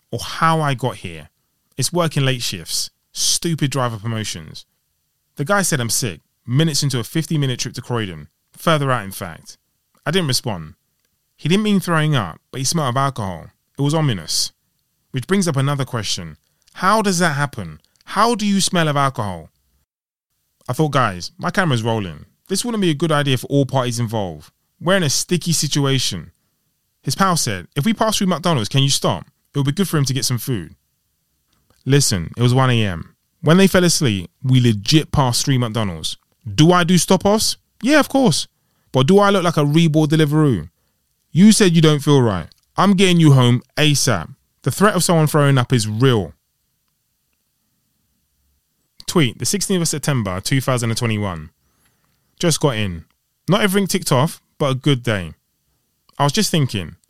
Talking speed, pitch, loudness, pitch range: 180 wpm, 135 Hz, -18 LUFS, 110-165 Hz